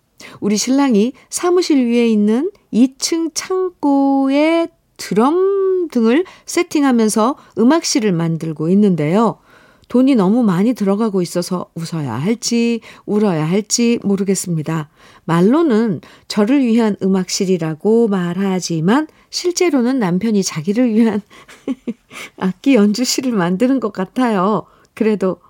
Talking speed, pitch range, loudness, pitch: 260 characters per minute, 190-270 Hz, -16 LUFS, 225 Hz